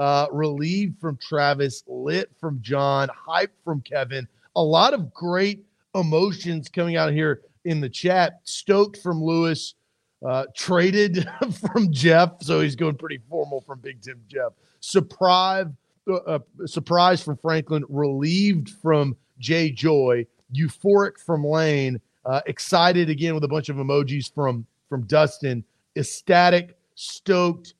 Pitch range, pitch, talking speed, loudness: 140-175 Hz, 160 Hz, 135 wpm, -22 LUFS